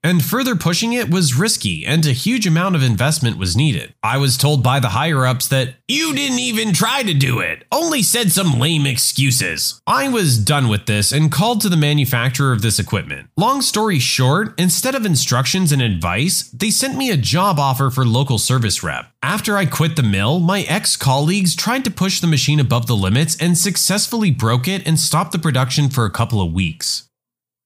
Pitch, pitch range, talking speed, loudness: 150 Hz, 130-190 Hz, 205 wpm, -16 LUFS